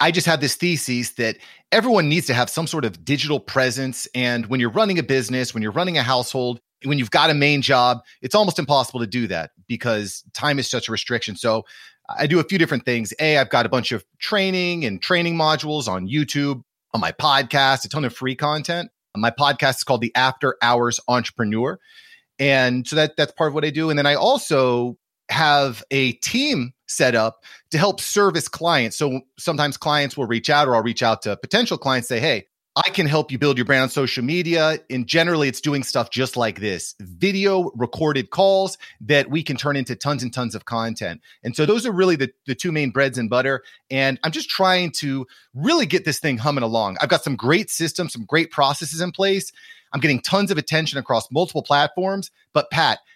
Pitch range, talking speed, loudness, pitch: 125-165 Hz, 215 wpm, -20 LUFS, 140 Hz